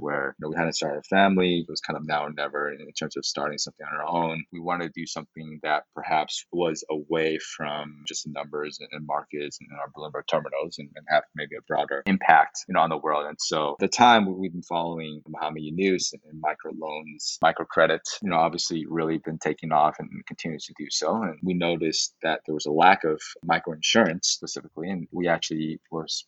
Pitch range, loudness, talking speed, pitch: 75-85 Hz, -26 LUFS, 225 wpm, 80 Hz